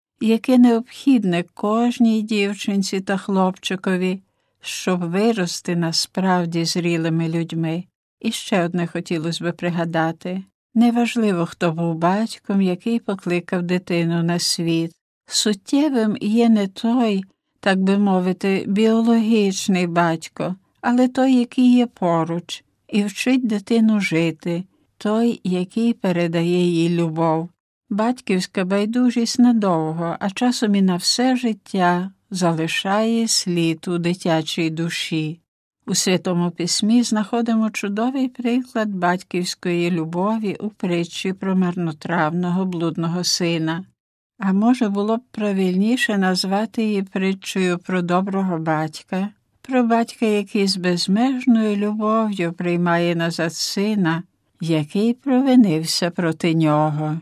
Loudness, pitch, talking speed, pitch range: -20 LUFS, 190 Hz, 105 wpm, 170-220 Hz